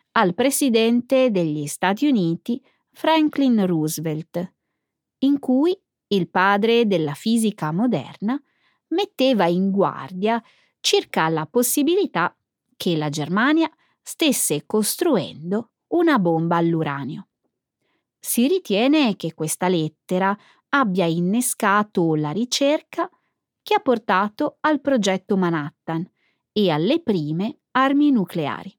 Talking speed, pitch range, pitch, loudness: 100 wpm, 170-275 Hz, 210 Hz, -21 LUFS